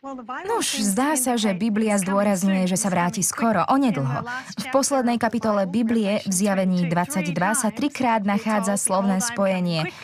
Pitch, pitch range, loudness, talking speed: 205 Hz, 190-235 Hz, -22 LUFS, 145 wpm